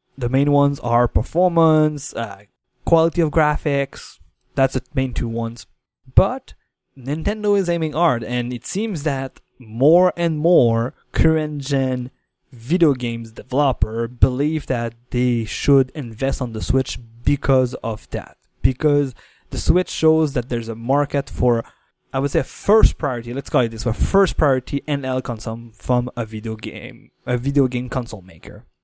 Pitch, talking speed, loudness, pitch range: 130 Hz, 155 wpm, -20 LUFS, 115-145 Hz